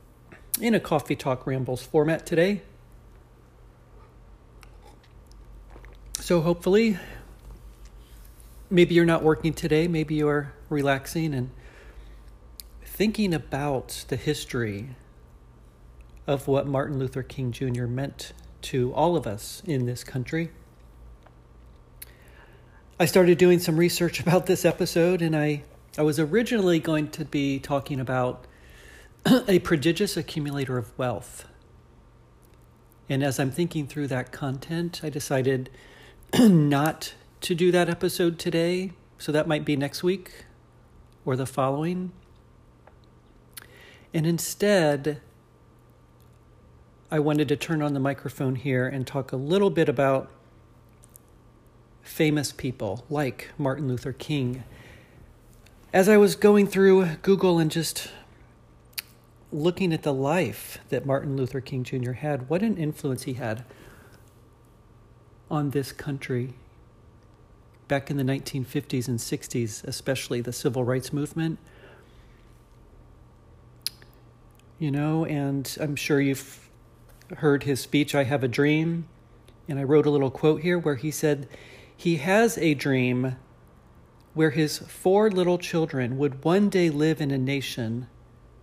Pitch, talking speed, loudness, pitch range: 140 Hz, 125 wpm, -25 LUFS, 125-160 Hz